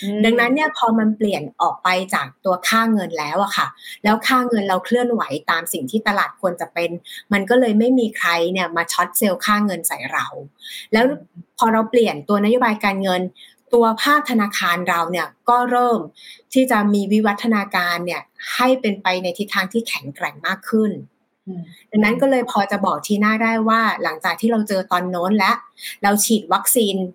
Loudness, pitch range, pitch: -18 LUFS, 185-230 Hz, 210 Hz